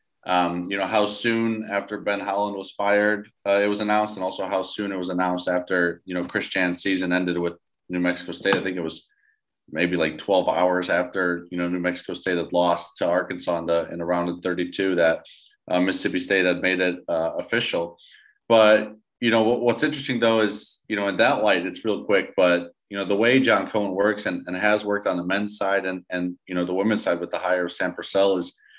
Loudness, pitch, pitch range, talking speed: -23 LUFS, 95 Hz, 90-105 Hz, 225 wpm